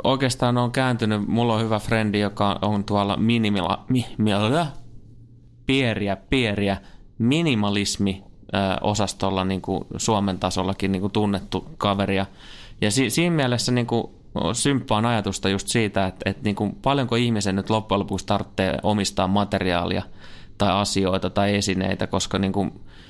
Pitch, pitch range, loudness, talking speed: 100 Hz, 95-115 Hz, -23 LUFS, 140 wpm